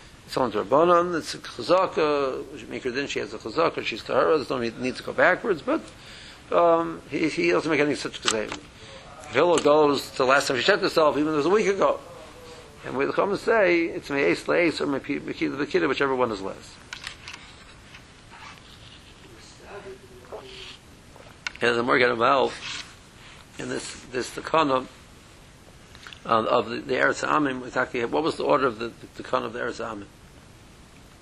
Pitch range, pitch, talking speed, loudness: 130-200 Hz, 150 Hz, 165 wpm, -24 LUFS